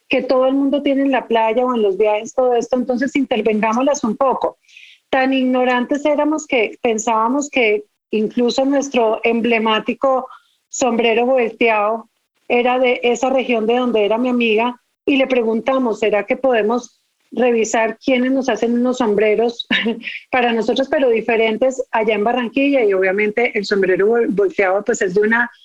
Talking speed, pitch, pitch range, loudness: 155 wpm, 240 Hz, 225-260 Hz, -17 LUFS